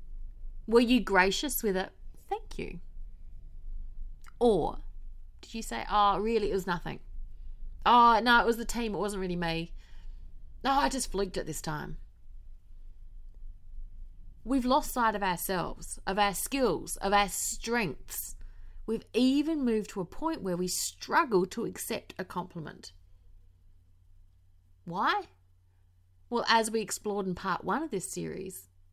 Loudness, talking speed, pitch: -29 LUFS, 145 wpm, 180 Hz